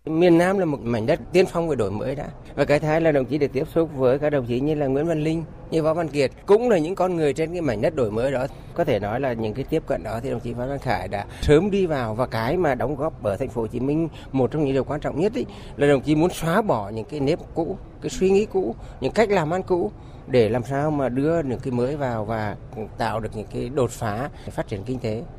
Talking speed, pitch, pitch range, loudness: 295 wpm, 140 Hz, 120-160 Hz, -23 LUFS